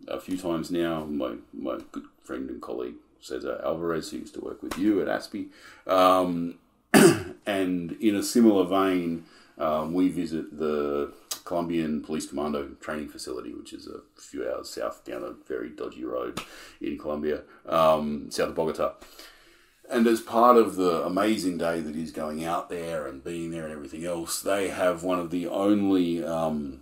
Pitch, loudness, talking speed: 95 Hz, -27 LUFS, 170 wpm